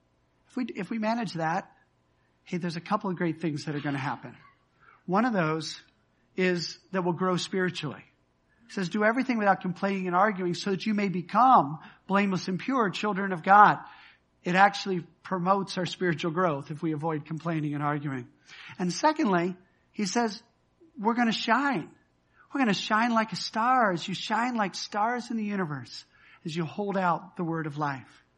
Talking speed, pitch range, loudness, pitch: 185 wpm, 165-210 Hz, -27 LUFS, 185 Hz